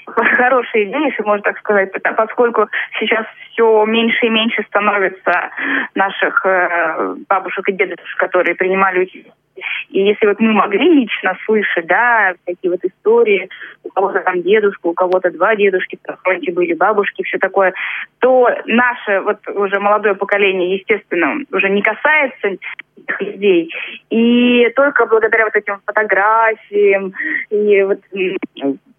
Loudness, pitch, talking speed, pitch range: -14 LUFS, 210 Hz, 135 wpm, 190-235 Hz